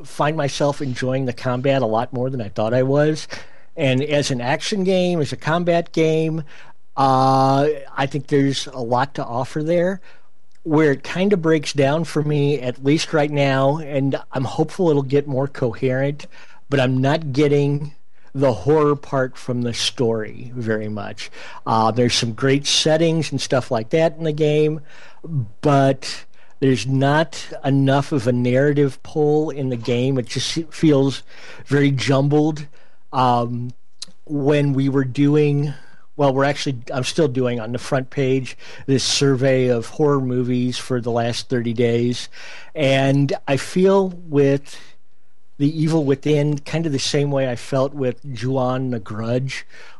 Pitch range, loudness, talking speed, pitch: 125-150 Hz, -19 LUFS, 160 wpm, 135 Hz